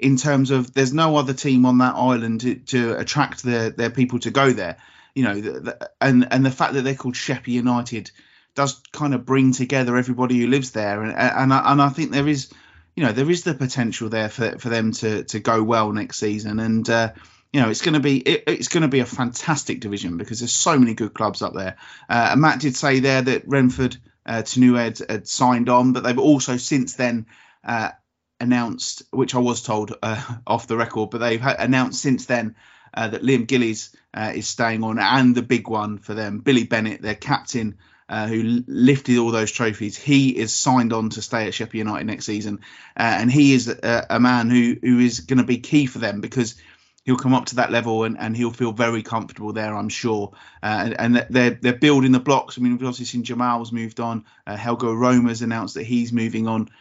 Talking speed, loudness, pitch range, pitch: 225 wpm, -20 LUFS, 110-130 Hz, 120 Hz